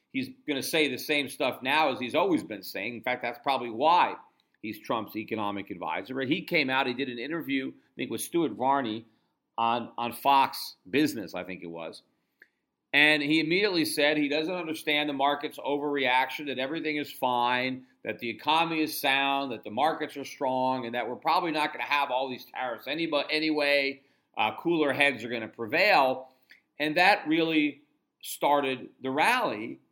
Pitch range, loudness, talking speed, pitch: 120-150 Hz, -27 LUFS, 185 wpm, 140 Hz